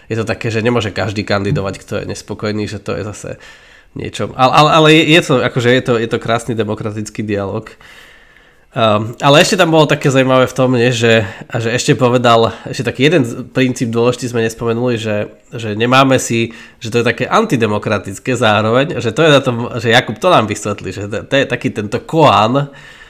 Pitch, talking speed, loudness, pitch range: 120 Hz, 200 wpm, -13 LUFS, 110-130 Hz